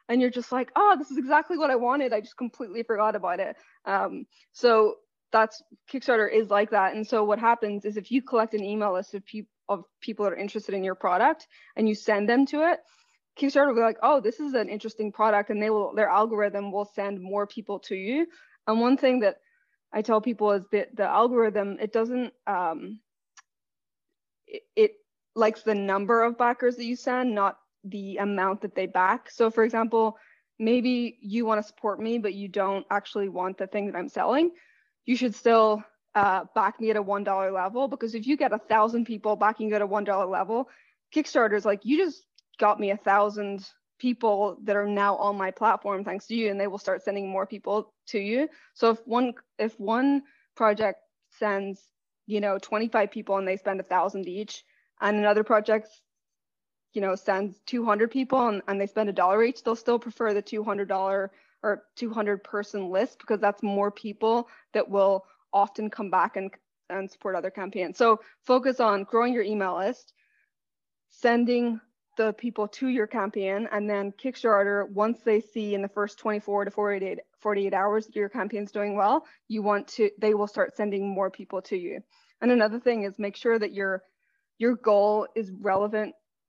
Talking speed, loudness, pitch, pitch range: 195 wpm, -26 LUFS, 215 Hz, 200-235 Hz